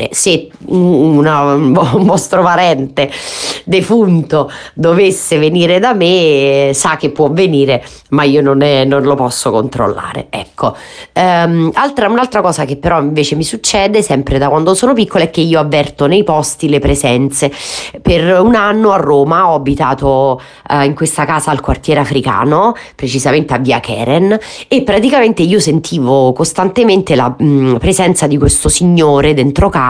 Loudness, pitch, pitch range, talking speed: -10 LUFS, 155 Hz, 140-185 Hz, 155 wpm